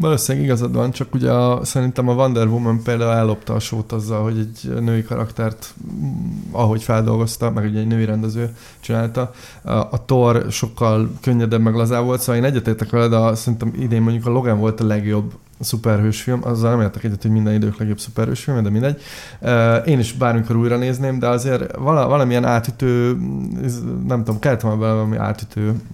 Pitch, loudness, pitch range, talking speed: 115 Hz, -19 LUFS, 110-125 Hz, 175 wpm